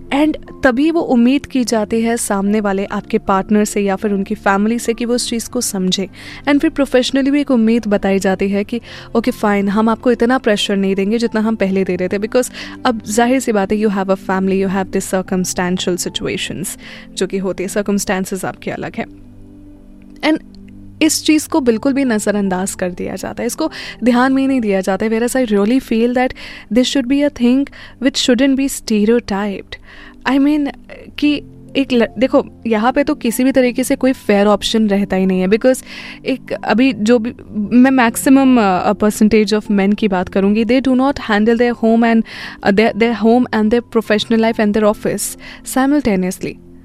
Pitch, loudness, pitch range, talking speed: 225 Hz, -15 LUFS, 200-255 Hz, 195 wpm